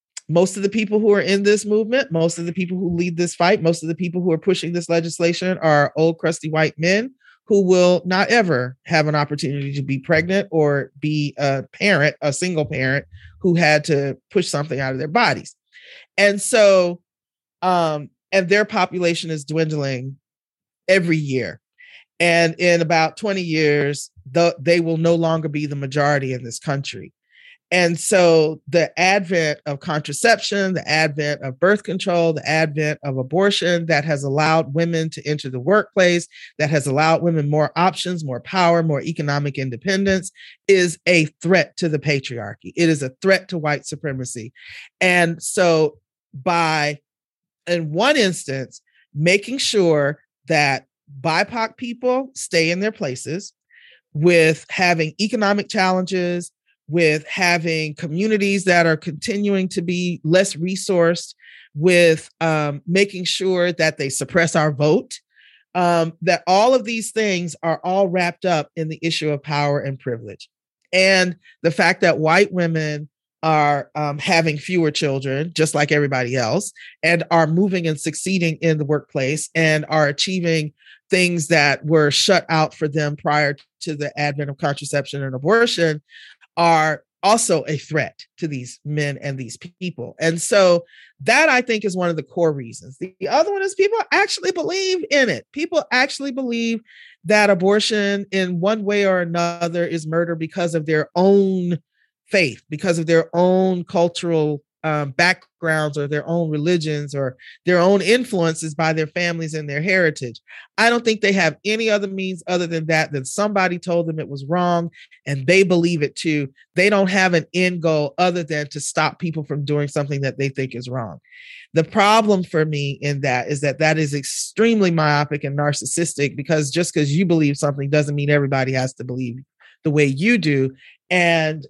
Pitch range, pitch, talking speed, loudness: 150-185 Hz, 165 Hz, 170 wpm, -19 LUFS